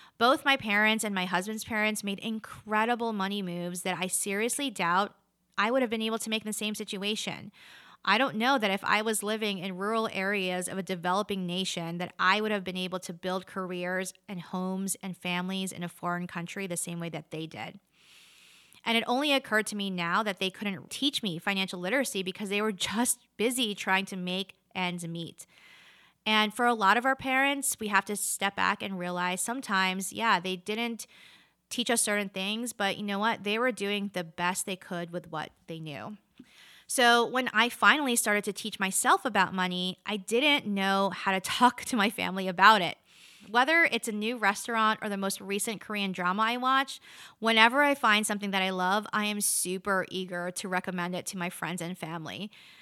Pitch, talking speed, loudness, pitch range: 200 Hz, 200 wpm, -28 LUFS, 185-225 Hz